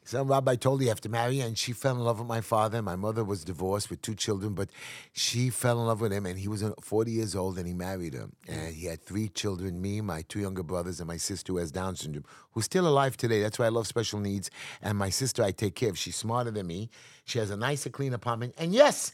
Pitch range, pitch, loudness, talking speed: 95-120 Hz, 110 Hz, -30 LUFS, 275 wpm